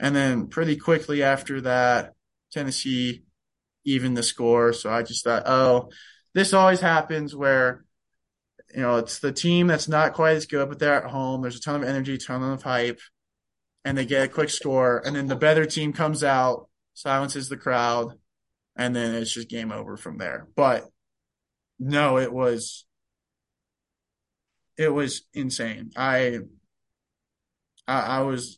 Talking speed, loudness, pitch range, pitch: 160 wpm, -23 LUFS, 120-145 Hz, 130 Hz